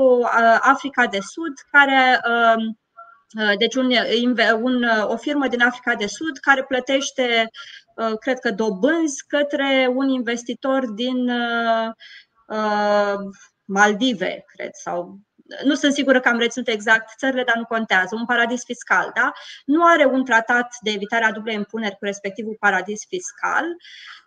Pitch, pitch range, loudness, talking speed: 240 Hz, 225-270 Hz, -19 LUFS, 130 wpm